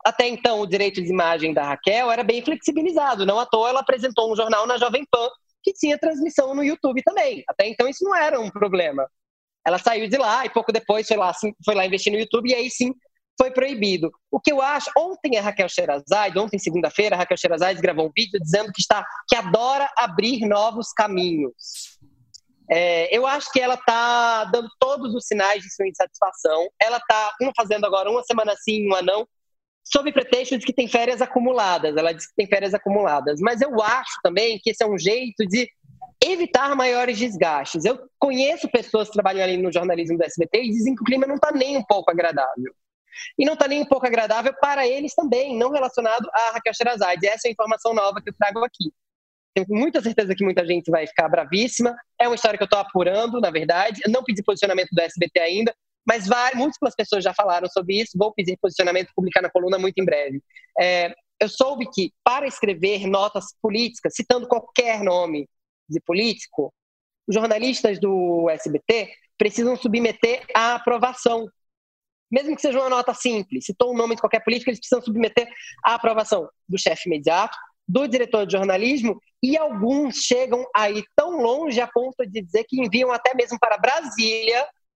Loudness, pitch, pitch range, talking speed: -21 LUFS, 225 Hz, 195-250 Hz, 195 wpm